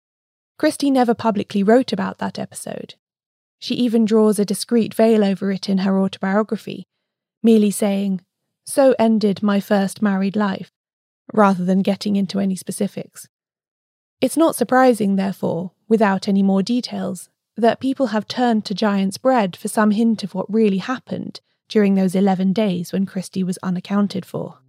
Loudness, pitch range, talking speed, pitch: -19 LUFS, 195-225 Hz, 155 wpm, 205 Hz